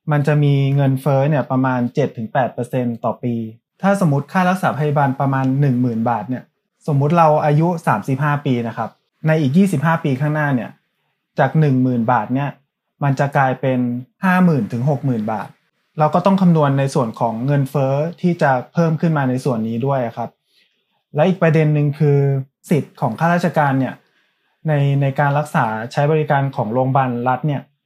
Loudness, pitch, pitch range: -18 LUFS, 140 Hz, 130-155 Hz